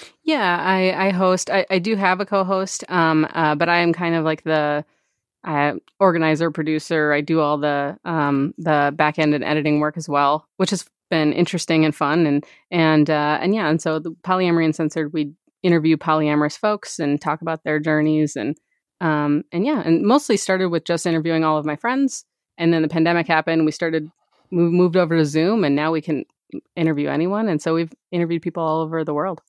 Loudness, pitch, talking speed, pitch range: -20 LUFS, 160 Hz, 205 wpm, 155-180 Hz